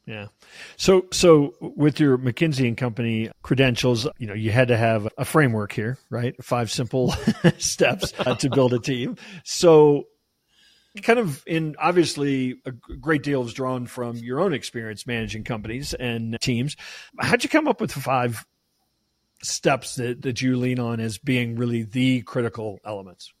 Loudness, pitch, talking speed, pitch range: -22 LUFS, 130 Hz, 160 wpm, 120-150 Hz